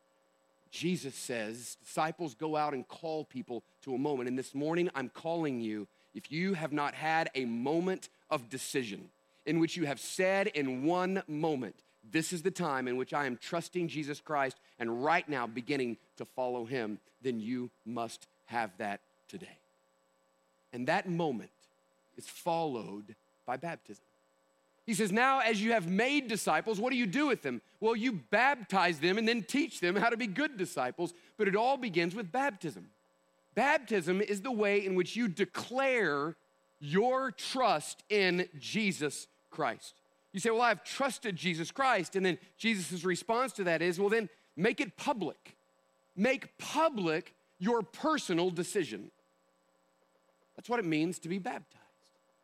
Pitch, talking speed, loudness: 165 Hz, 165 wpm, -33 LUFS